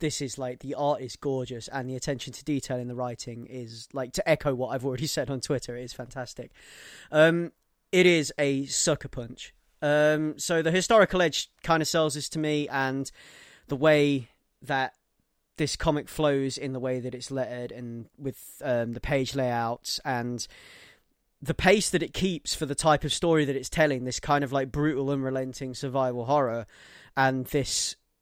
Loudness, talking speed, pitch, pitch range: -27 LUFS, 190 wpm, 135 Hz, 125-150 Hz